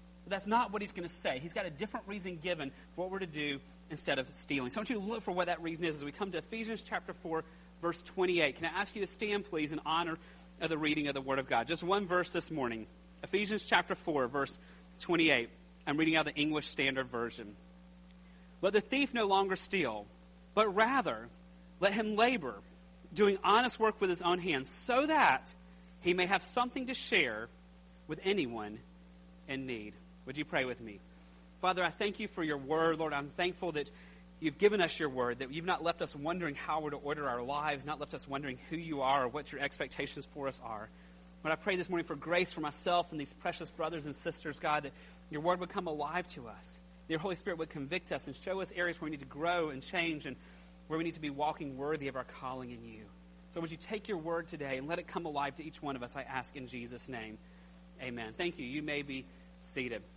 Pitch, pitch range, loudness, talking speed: 155 Hz, 120-180 Hz, -35 LUFS, 235 wpm